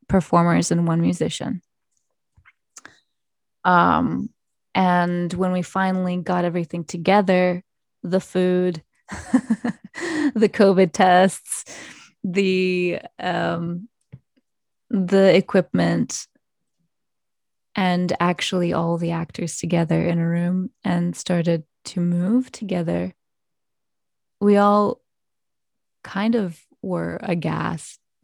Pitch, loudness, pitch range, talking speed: 180 Hz, -21 LUFS, 170-195 Hz, 85 wpm